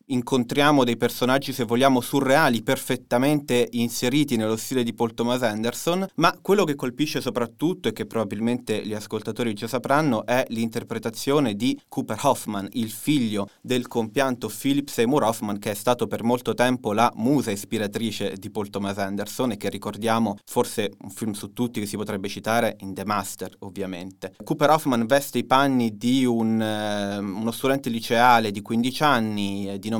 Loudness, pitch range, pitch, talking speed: -24 LUFS, 105-130 Hz, 120 Hz, 165 wpm